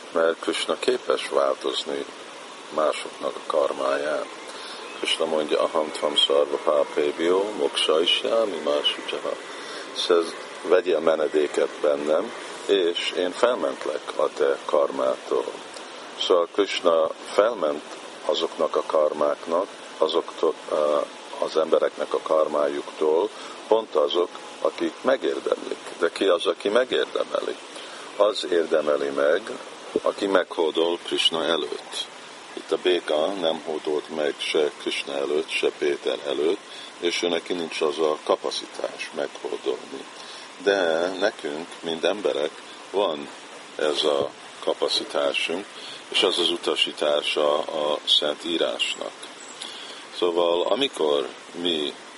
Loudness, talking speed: -24 LUFS, 105 wpm